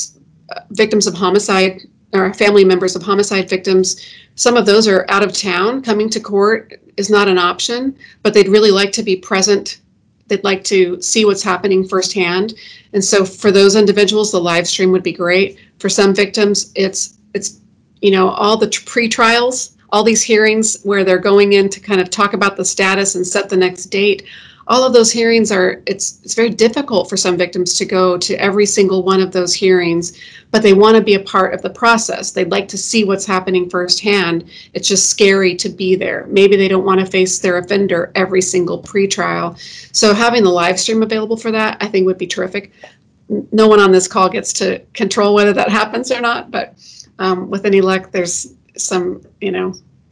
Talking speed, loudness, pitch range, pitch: 200 wpm, -13 LUFS, 185-210 Hz, 195 Hz